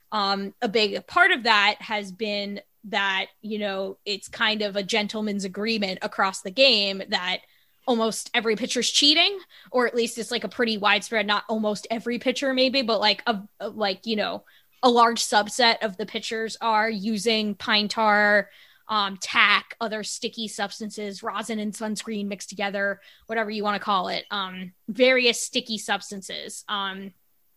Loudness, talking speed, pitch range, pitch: -23 LUFS, 160 wpm, 205-230 Hz, 215 Hz